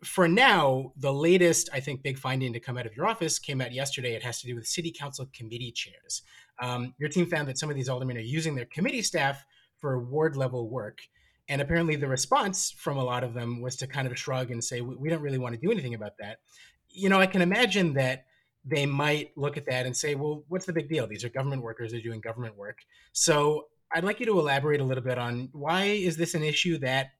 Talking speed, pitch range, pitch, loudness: 245 wpm, 125-160 Hz, 135 Hz, -28 LUFS